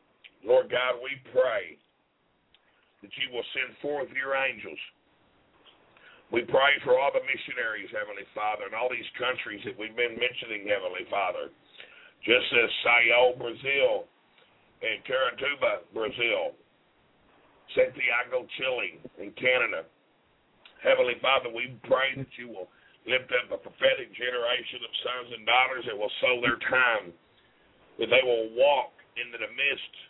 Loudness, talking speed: -27 LUFS, 135 wpm